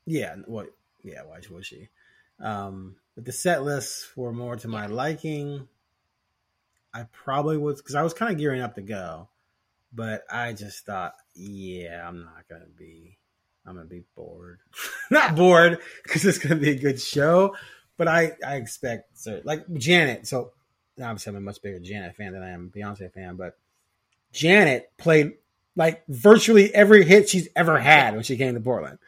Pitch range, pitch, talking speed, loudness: 100-155 Hz, 125 Hz, 180 wpm, -20 LUFS